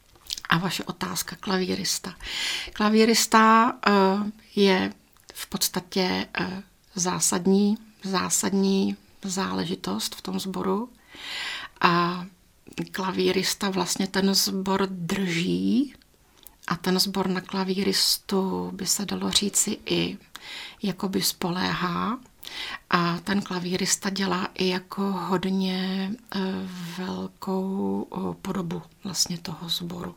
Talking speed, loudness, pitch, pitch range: 90 wpm, -25 LUFS, 190 Hz, 180-195 Hz